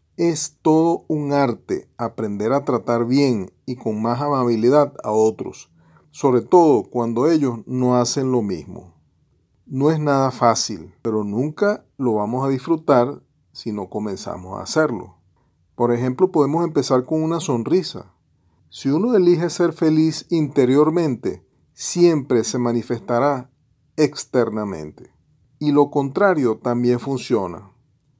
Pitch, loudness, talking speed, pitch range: 130 Hz, -20 LUFS, 125 wpm, 120-150 Hz